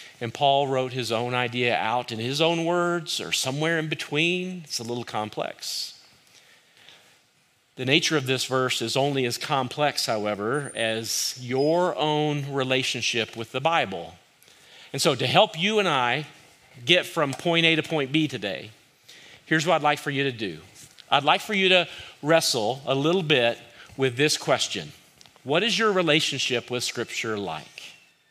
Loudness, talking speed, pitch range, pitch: -24 LUFS, 165 wpm, 125-165 Hz, 140 Hz